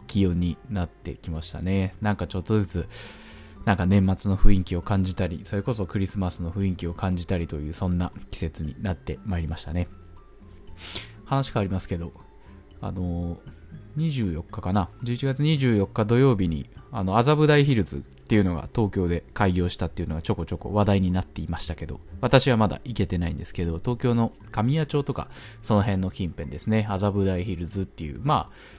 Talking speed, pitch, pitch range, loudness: 365 characters per minute, 95 Hz, 85-105 Hz, -26 LUFS